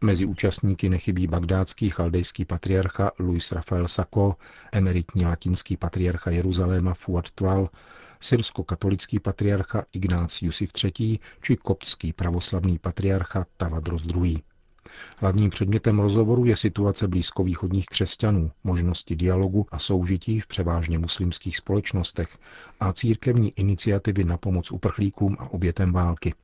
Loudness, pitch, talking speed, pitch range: -25 LUFS, 95 Hz, 110 wpm, 90-100 Hz